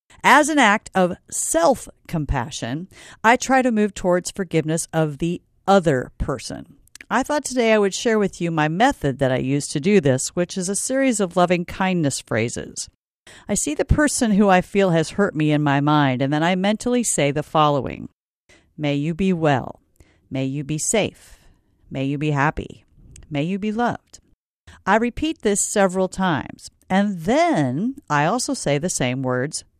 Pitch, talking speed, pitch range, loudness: 180 Hz, 180 wpm, 150-210 Hz, -20 LUFS